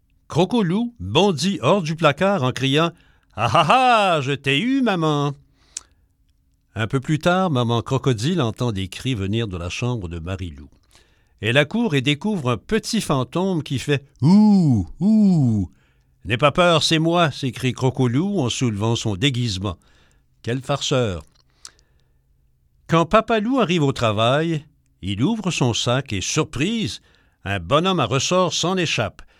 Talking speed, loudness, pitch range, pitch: 145 wpm, -20 LUFS, 105-170 Hz, 135 Hz